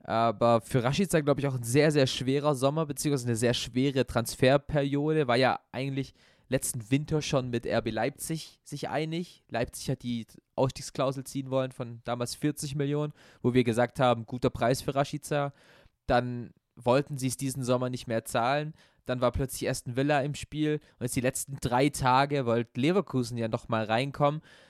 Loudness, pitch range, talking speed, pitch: -29 LUFS, 120-145 Hz, 175 wpm, 130 Hz